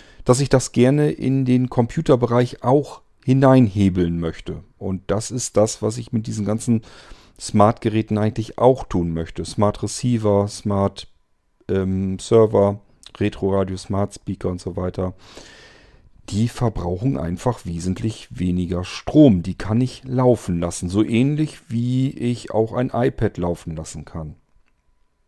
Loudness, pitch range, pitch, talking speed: -20 LUFS, 95-125 Hz, 105 Hz, 125 wpm